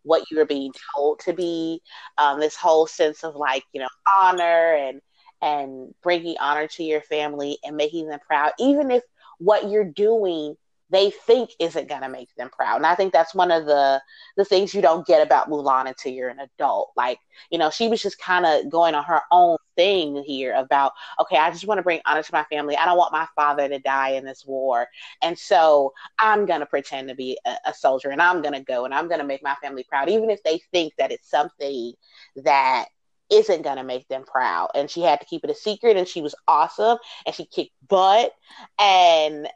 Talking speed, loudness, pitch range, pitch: 215 wpm, -21 LUFS, 140-185 Hz, 155 Hz